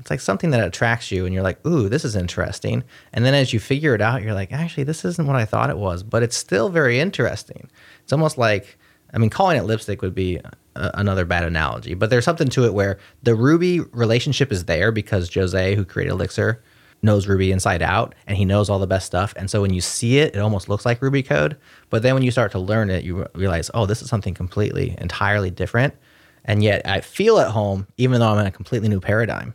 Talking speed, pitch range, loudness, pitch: 240 wpm, 95-125 Hz, -20 LUFS, 105 Hz